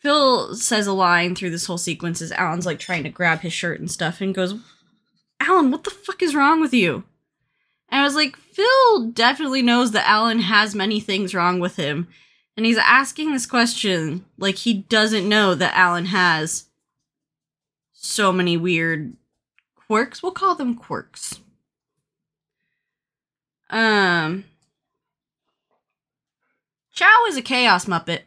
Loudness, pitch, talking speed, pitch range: -19 LUFS, 200 Hz, 145 wpm, 175-250 Hz